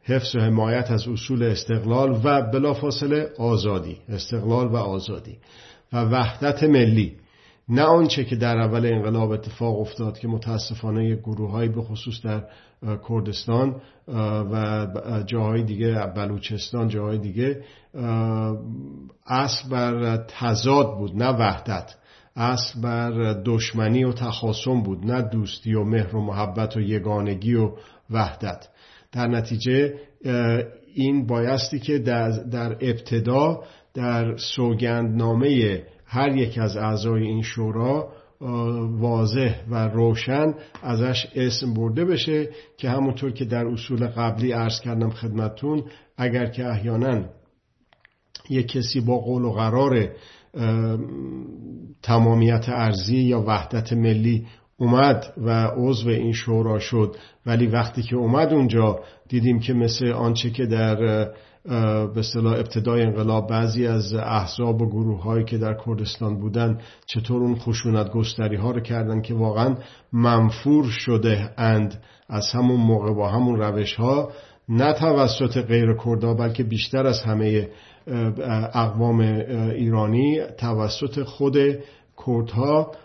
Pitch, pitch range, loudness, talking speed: 115 Hz, 110-125 Hz, -23 LUFS, 120 wpm